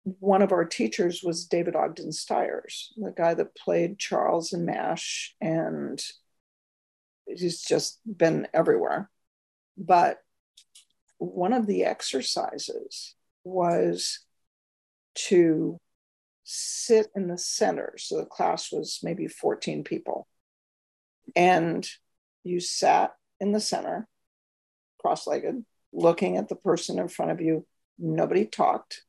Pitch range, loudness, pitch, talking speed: 165-215 Hz, -27 LUFS, 180 Hz, 115 wpm